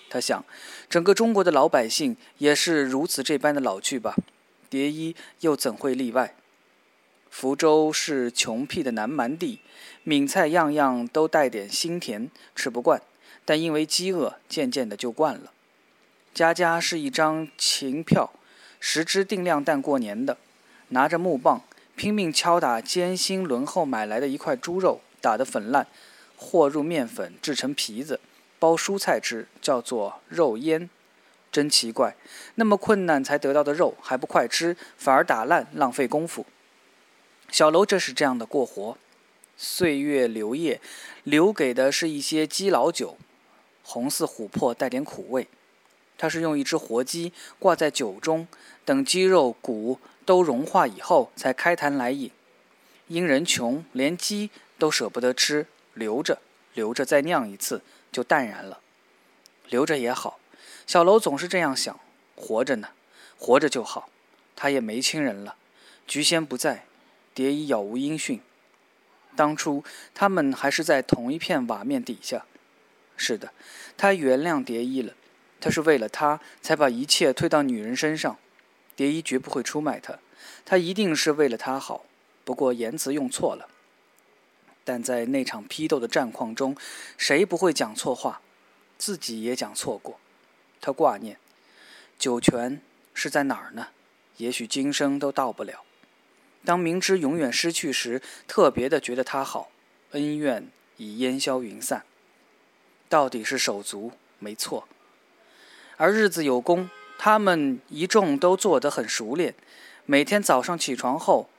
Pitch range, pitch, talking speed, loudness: 135-180 Hz, 155 Hz, 215 characters per minute, -24 LUFS